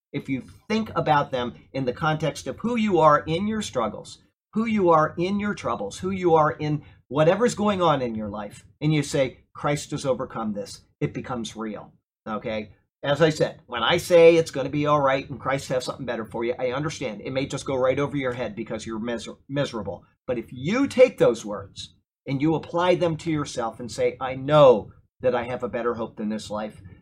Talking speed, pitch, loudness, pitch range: 220 wpm, 135 Hz, -24 LUFS, 115-160 Hz